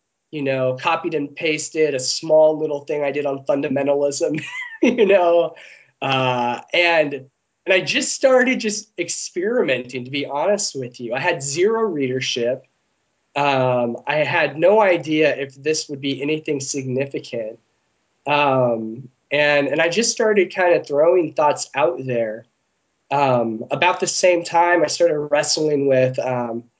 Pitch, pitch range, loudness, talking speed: 145 Hz, 130-170 Hz, -19 LUFS, 145 wpm